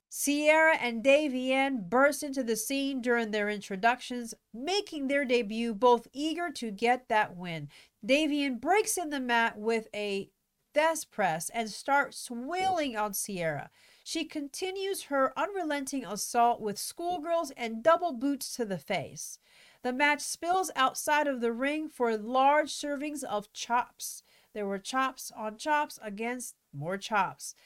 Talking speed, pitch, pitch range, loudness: 145 wpm, 260 Hz, 225-295 Hz, -30 LUFS